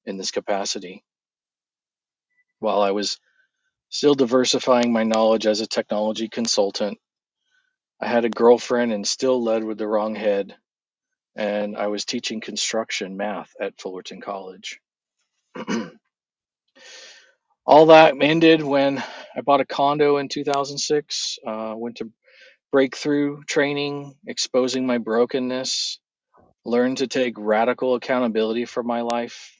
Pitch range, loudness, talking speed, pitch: 110-140 Hz, -21 LUFS, 120 wpm, 125 Hz